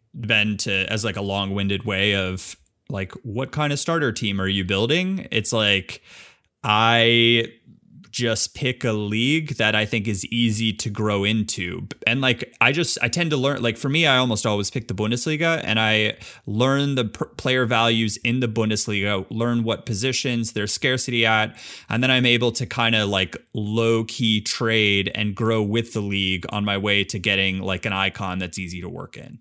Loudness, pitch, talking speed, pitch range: -21 LUFS, 110 Hz, 195 wpm, 100-120 Hz